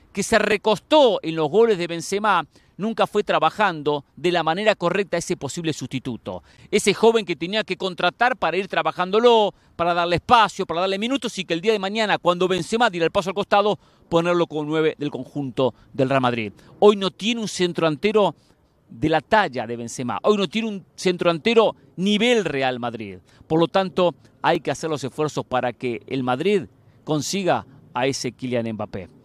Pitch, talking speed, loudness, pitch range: 170 Hz, 185 wpm, -21 LUFS, 135-200 Hz